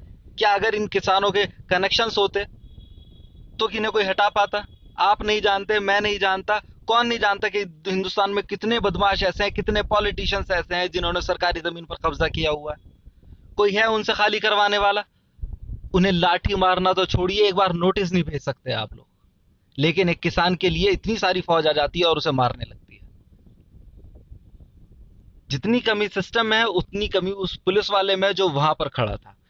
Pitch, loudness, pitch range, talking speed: 190 Hz, -21 LUFS, 155-205 Hz, 185 wpm